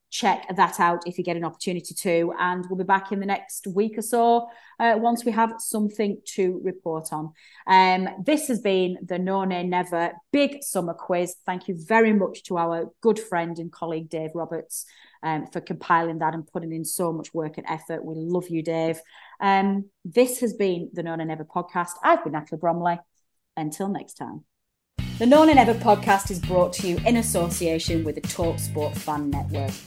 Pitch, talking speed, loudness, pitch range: 180 Hz, 200 wpm, -24 LUFS, 165-205 Hz